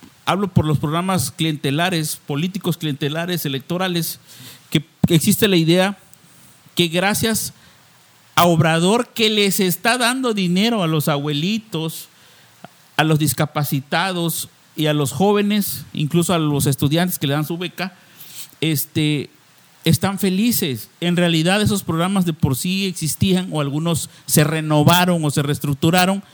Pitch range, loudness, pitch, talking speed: 150-185 Hz, -18 LUFS, 165 Hz, 130 wpm